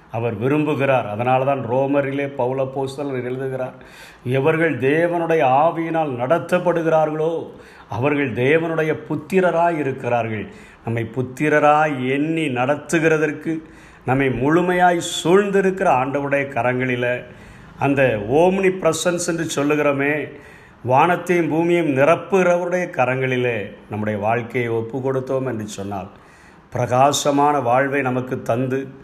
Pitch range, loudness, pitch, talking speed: 125-160 Hz, -19 LUFS, 140 Hz, 90 wpm